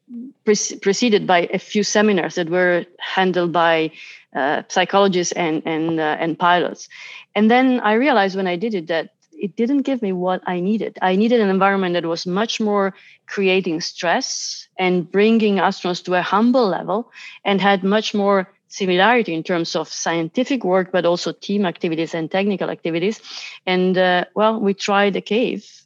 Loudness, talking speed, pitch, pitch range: -19 LUFS, 170 wpm, 190 Hz, 175-210 Hz